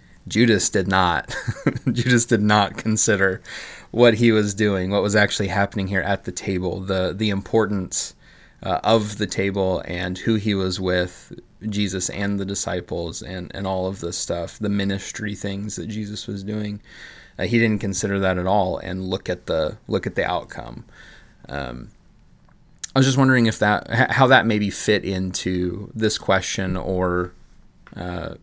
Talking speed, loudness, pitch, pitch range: 165 wpm, -21 LUFS, 100 Hz, 95-110 Hz